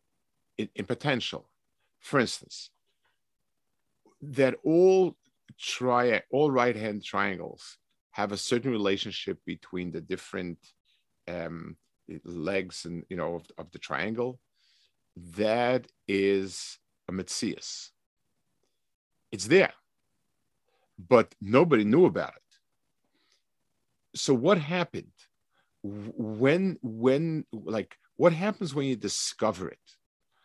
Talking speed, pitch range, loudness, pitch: 100 wpm, 95-135 Hz, -28 LUFS, 110 Hz